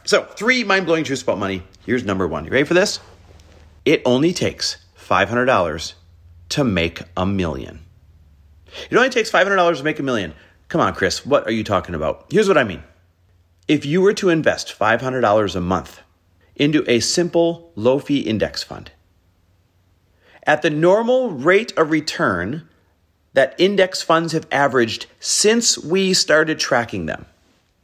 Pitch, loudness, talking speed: 110 Hz, -18 LUFS, 155 wpm